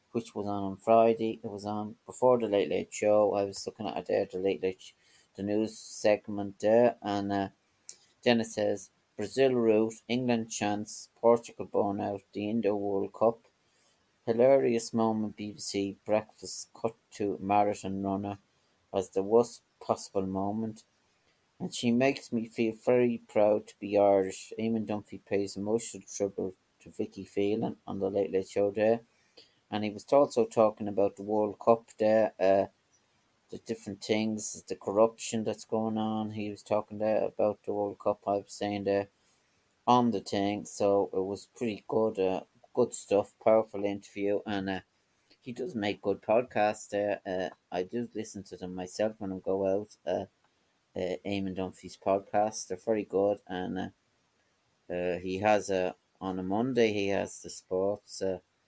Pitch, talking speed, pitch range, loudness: 105 Hz, 170 wpm, 100-110 Hz, -30 LUFS